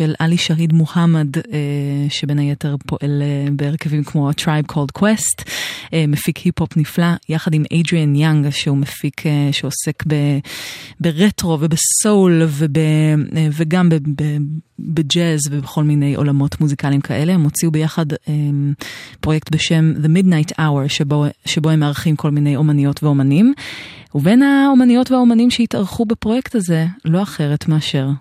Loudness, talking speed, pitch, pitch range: -16 LUFS, 125 wpm, 155 Hz, 145-170 Hz